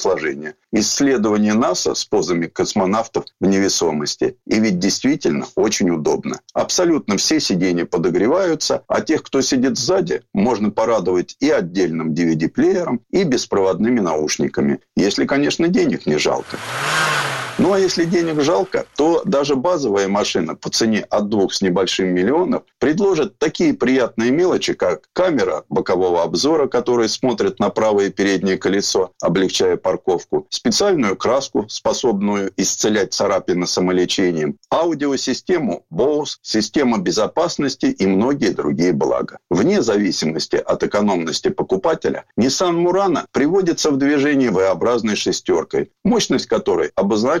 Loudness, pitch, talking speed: -18 LUFS, 120 Hz, 120 wpm